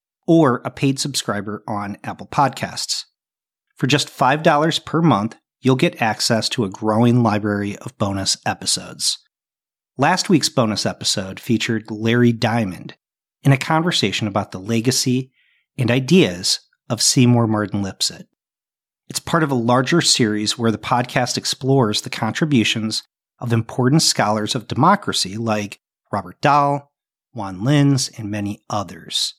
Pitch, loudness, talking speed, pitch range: 120 Hz, -19 LUFS, 135 wpm, 110-140 Hz